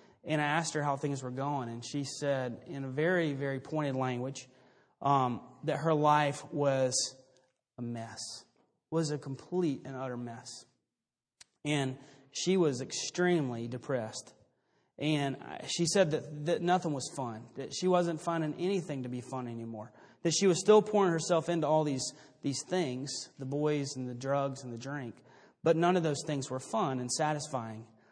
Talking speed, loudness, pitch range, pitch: 175 wpm, -32 LUFS, 130-155 Hz, 140 Hz